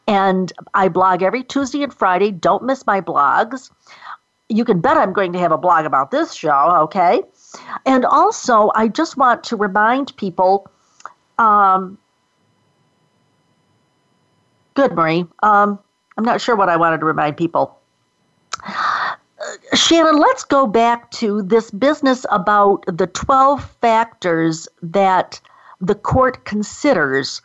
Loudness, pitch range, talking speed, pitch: -16 LUFS, 190-260 Hz, 135 wpm, 210 Hz